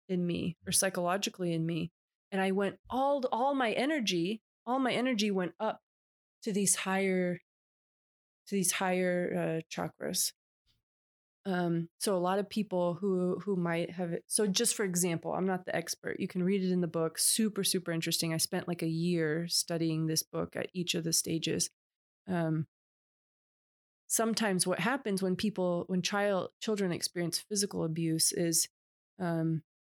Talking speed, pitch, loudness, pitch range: 165 wpm, 180 Hz, -32 LUFS, 165-200 Hz